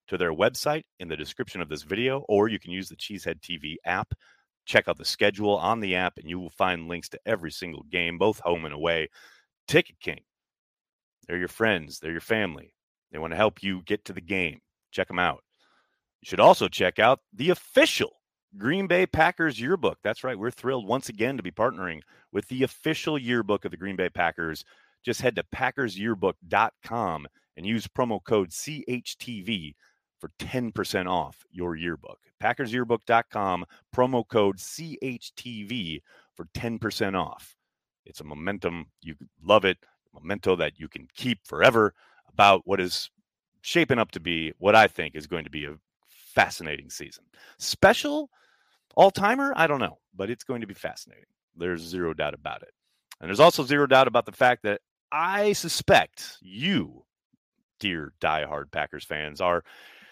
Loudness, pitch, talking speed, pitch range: -26 LUFS, 105 Hz, 170 wpm, 90-130 Hz